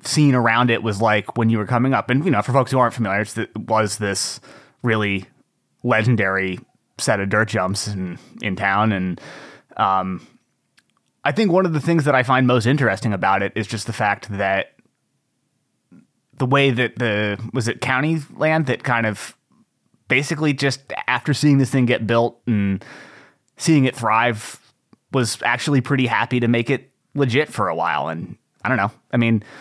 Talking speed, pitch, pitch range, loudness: 180 wpm, 115 Hz, 105-135 Hz, -19 LUFS